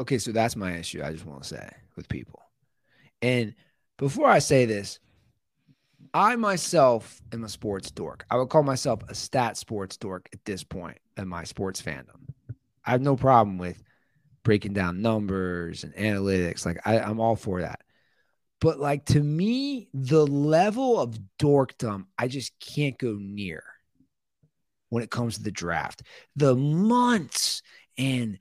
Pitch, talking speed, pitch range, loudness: 120 Hz, 160 wpm, 100-140 Hz, -26 LUFS